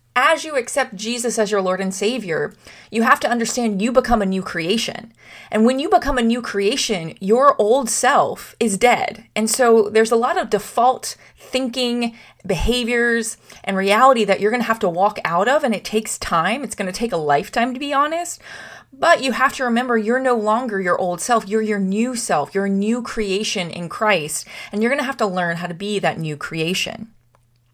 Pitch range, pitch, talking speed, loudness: 195-245 Hz, 225 Hz, 210 wpm, -19 LUFS